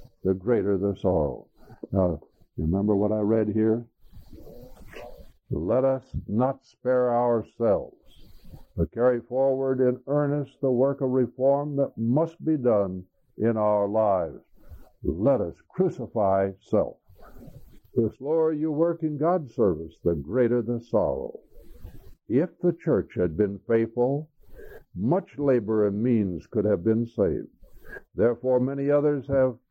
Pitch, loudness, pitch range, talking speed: 120 Hz, -25 LUFS, 110-140 Hz, 130 wpm